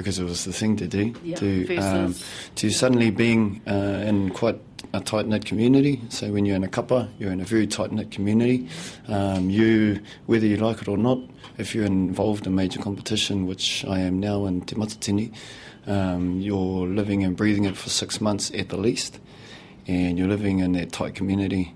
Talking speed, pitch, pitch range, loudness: 200 wpm, 100 Hz, 95-110 Hz, -24 LUFS